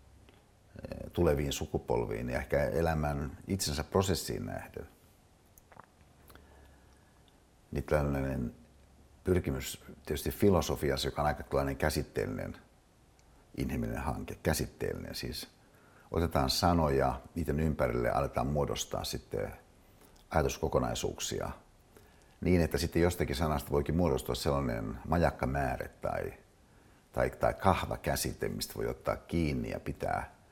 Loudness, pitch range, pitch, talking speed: -33 LUFS, 70-85 Hz, 75 Hz, 100 wpm